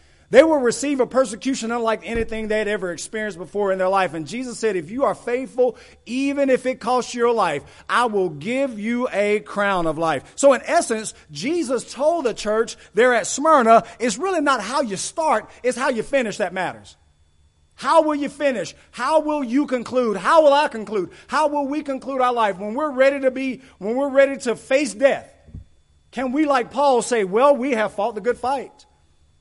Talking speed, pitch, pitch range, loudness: 200 wpm, 245 Hz, 210-275 Hz, -20 LUFS